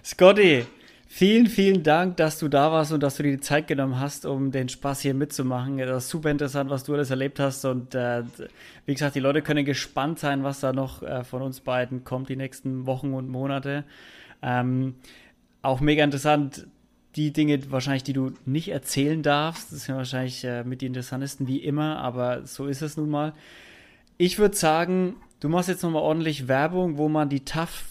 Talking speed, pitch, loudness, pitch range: 200 wpm, 140 Hz, -25 LUFS, 130-150 Hz